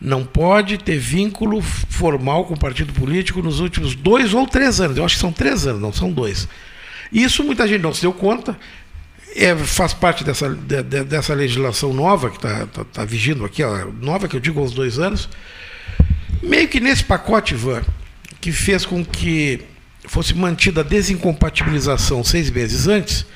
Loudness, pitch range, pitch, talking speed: -18 LUFS, 130-190 Hz, 155 Hz, 180 wpm